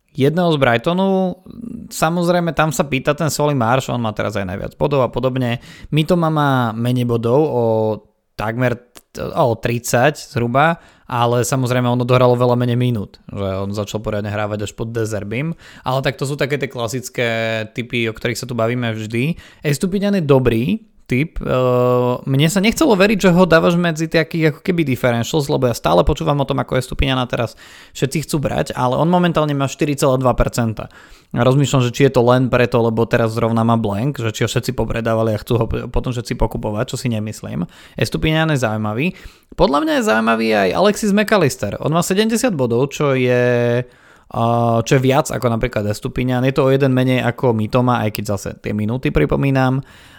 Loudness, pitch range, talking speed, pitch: -17 LUFS, 115-150 Hz, 180 wpm, 125 Hz